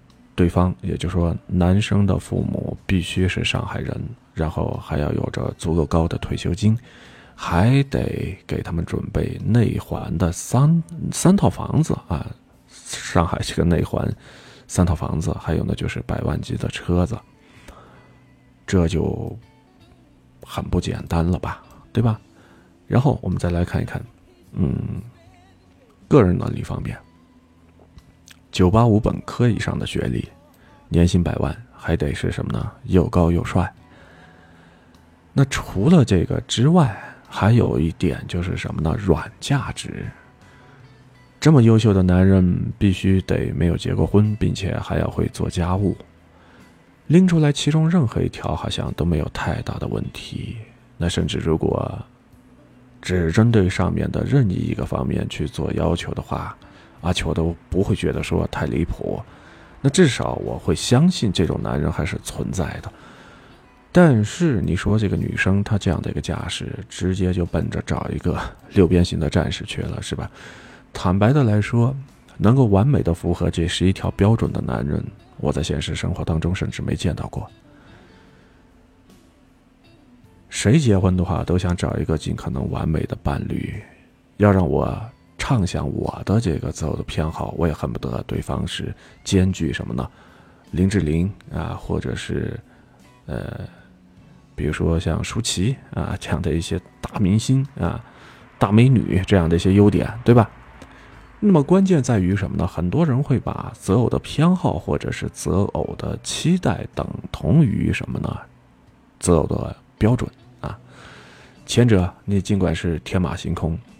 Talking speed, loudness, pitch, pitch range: 225 characters per minute, -21 LUFS, 95 Hz, 85-120 Hz